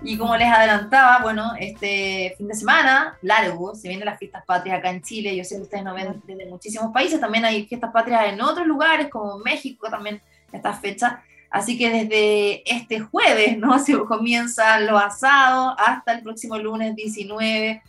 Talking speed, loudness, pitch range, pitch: 180 wpm, -19 LUFS, 205-240 Hz, 220 Hz